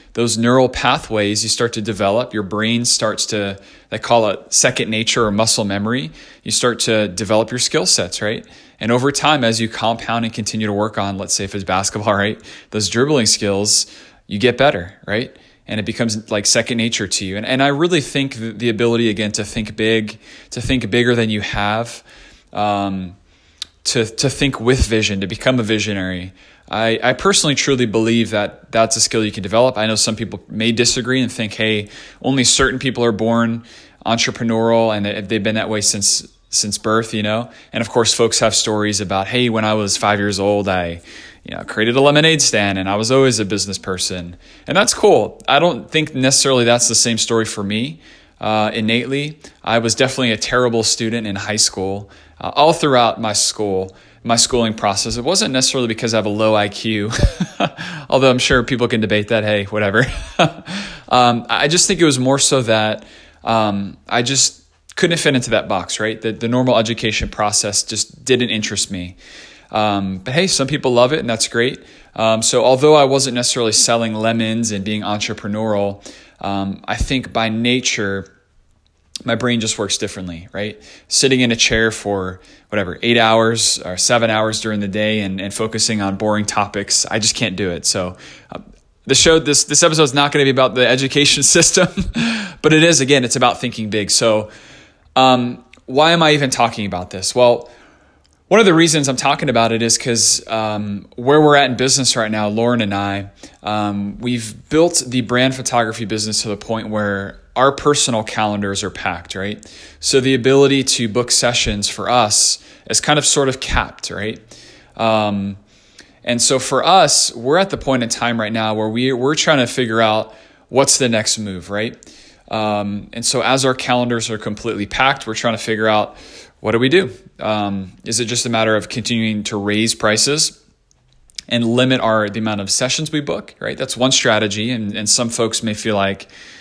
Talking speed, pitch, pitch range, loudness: 195 wpm, 115 Hz, 105-125 Hz, -16 LUFS